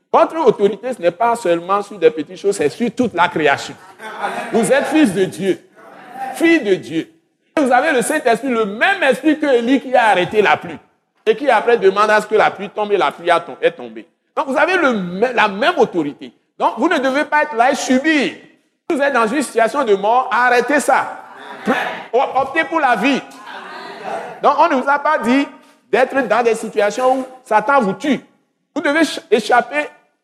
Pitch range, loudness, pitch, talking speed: 215-300 Hz, -16 LUFS, 260 Hz, 195 wpm